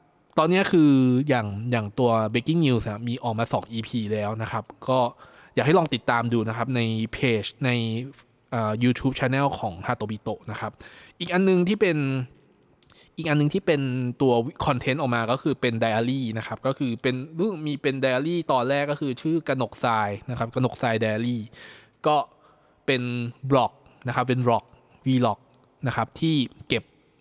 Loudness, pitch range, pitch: -25 LUFS, 115-140 Hz, 125 Hz